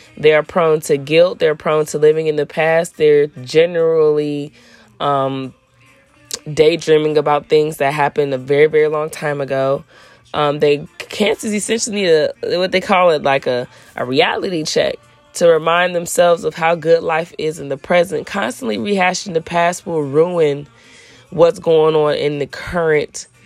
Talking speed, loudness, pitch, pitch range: 165 wpm, -16 LUFS, 155 Hz, 145-170 Hz